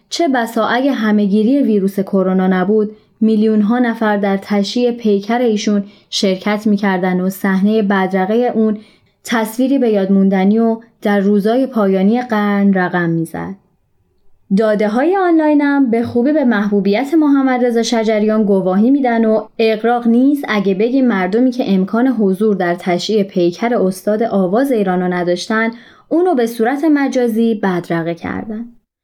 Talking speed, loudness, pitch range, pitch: 135 wpm, -14 LUFS, 195-235 Hz, 215 Hz